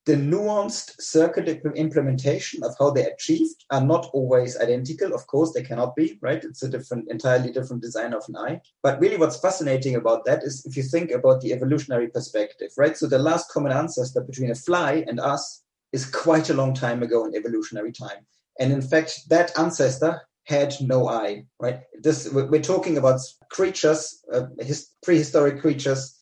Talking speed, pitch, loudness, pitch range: 180 wpm, 145 Hz, -23 LUFS, 130-160 Hz